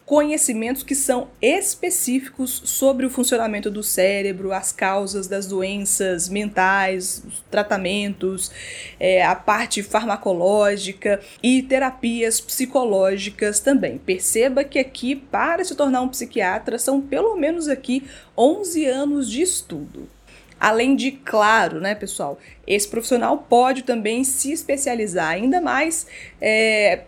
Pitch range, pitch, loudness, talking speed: 200-270 Hz, 235 Hz, -20 LUFS, 120 wpm